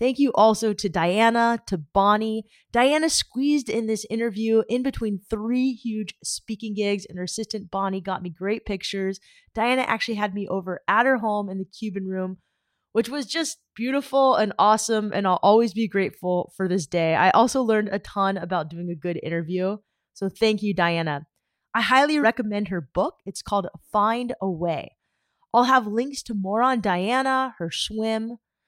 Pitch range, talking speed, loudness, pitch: 190-235 Hz, 180 wpm, -23 LUFS, 215 Hz